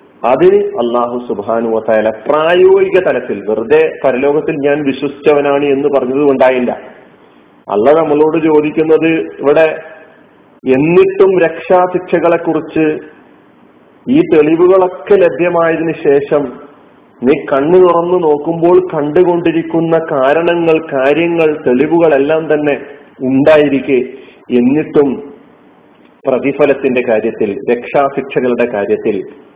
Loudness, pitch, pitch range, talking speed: -11 LUFS, 155 Hz, 140-170 Hz, 80 wpm